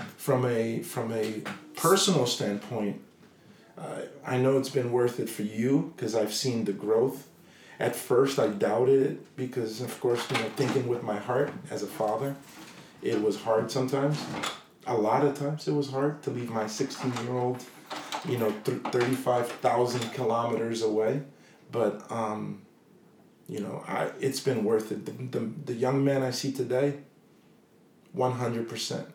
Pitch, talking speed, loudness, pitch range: 125 Hz, 160 wpm, -29 LUFS, 115-135 Hz